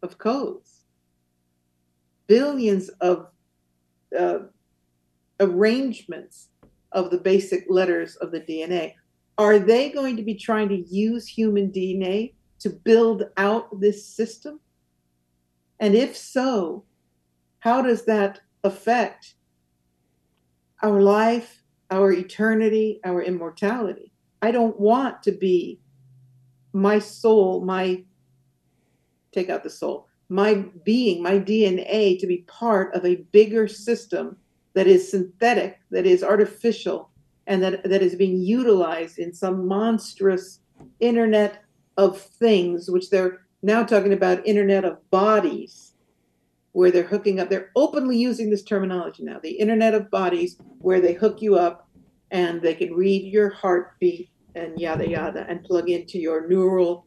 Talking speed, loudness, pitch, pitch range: 130 wpm, -22 LUFS, 190 Hz, 170-210 Hz